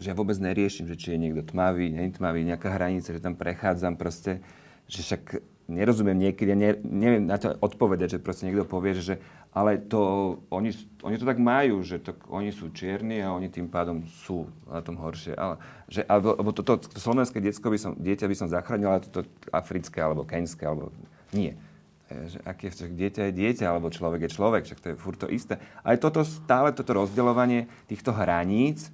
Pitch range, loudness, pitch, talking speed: 85-105 Hz, -28 LUFS, 95 Hz, 205 wpm